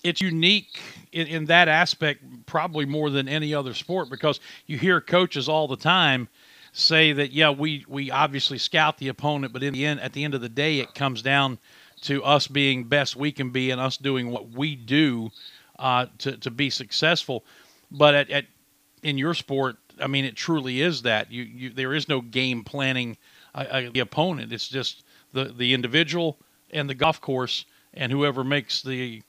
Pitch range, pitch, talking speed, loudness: 130-155 Hz, 140 Hz, 195 wpm, -23 LUFS